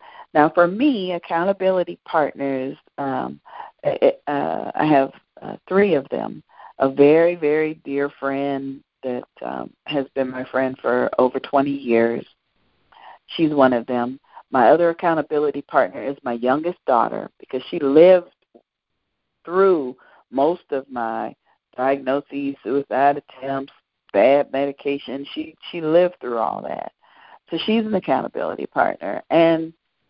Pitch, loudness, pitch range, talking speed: 145 Hz, -20 LUFS, 135-175 Hz, 130 wpm